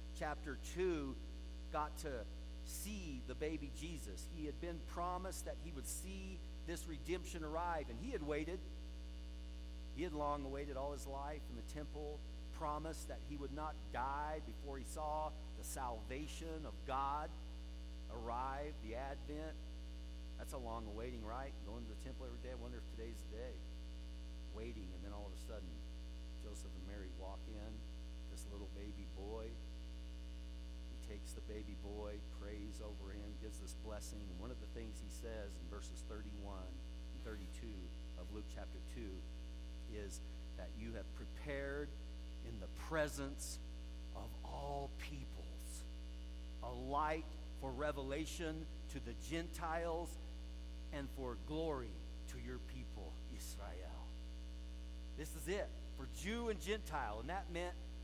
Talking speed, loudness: 145 wpm, -48 LUFS